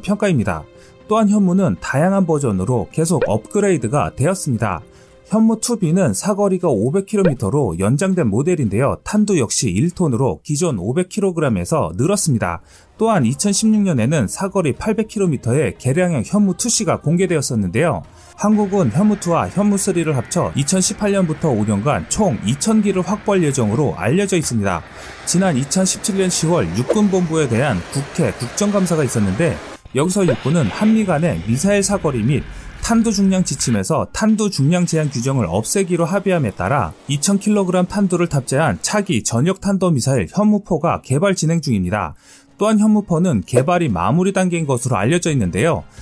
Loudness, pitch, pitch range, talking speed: -17 LUFS, 175 Hz, 130-200 Hz, 325 characters per minute